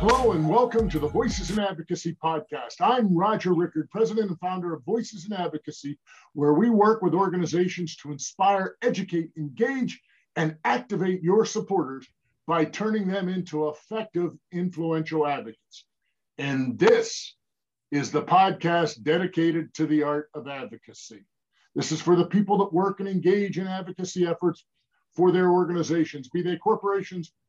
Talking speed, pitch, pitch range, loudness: 150 wpm, 175 Hz, 155-195 Hz, -25 LUFS